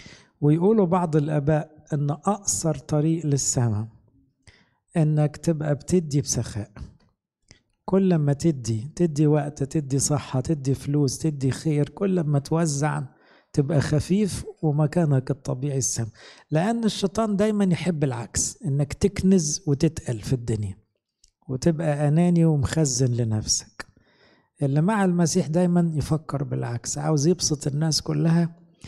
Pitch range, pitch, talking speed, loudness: 135-170 Hz, 150 Hz, 110 wpm, -24 LUFS